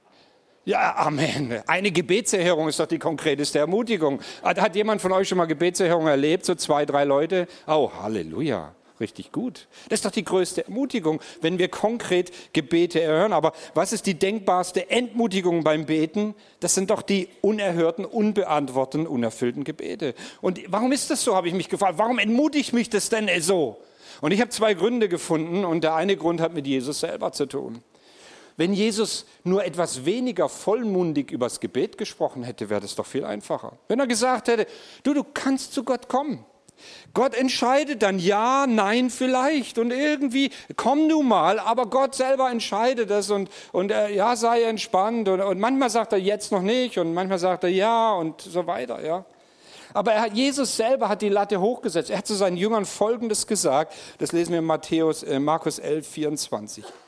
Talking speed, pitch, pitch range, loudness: 185 wpm, 195 Hz, 165-230 Hz, -23 LUFS